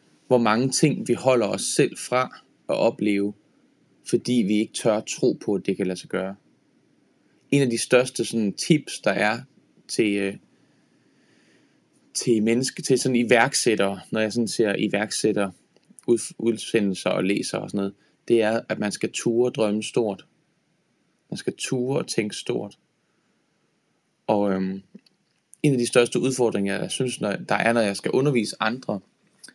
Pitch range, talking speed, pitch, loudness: 100-125 Hz, 155 wpm, 115 Hz, -23 LUFS